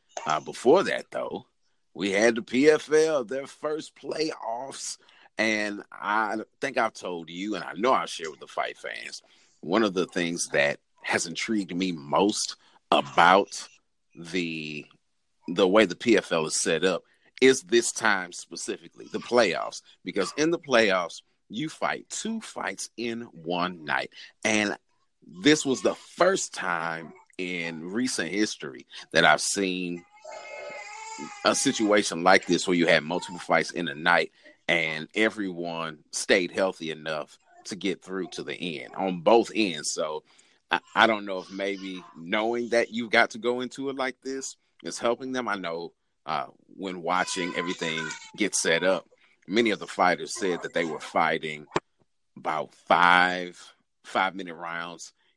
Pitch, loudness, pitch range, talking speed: 100 Hz, -26 LUFS, 85-125 Hz, 155 wpm